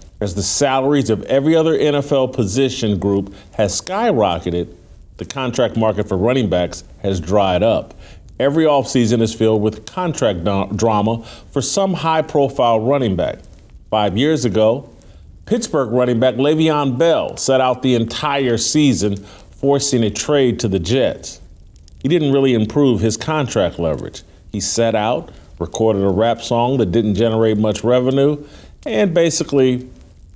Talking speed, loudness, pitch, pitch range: 140 wpm, -17 LUFS, 115 Hz, 100-140 Hz